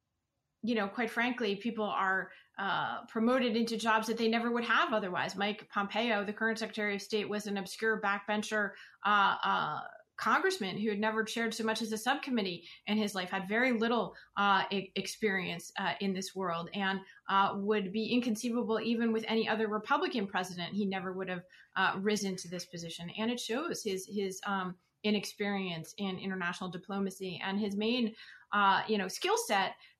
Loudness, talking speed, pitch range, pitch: -33 LUFS, 180 wpm, 190-225 Hz, 205 Hz